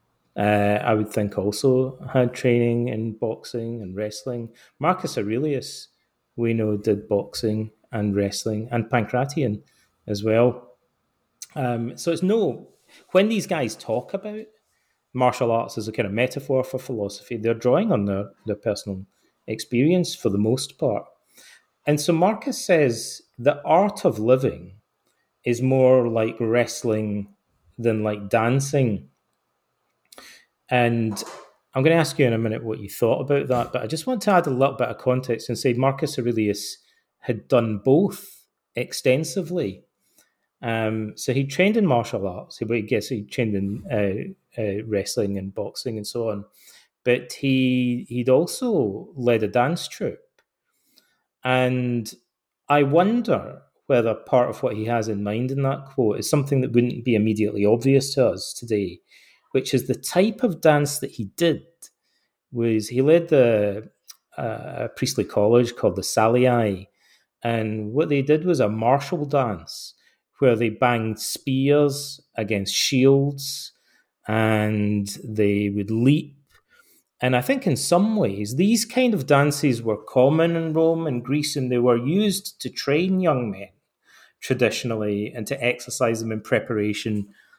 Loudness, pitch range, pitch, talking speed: -22 LUFS, 110-145 Hz, 125 Hz, 150 wpm